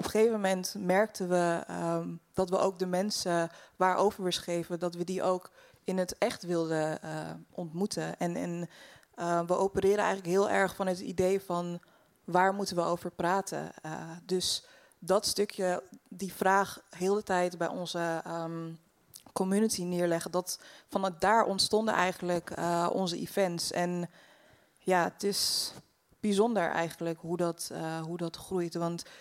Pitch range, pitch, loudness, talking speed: 170-195 Hz, 180 Hz, -31 LUFS, 155 wpm